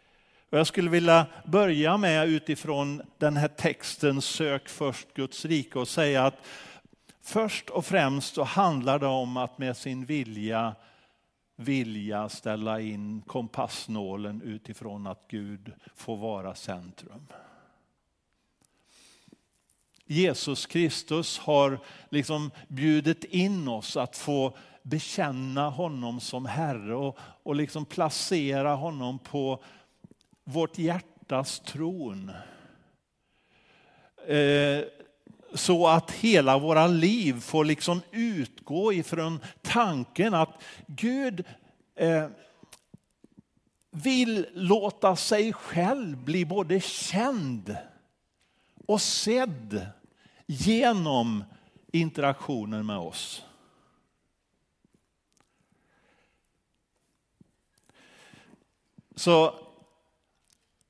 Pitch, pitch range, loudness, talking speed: 150 Hz, 125-175 Hz, -27 LUFS, 85 wpm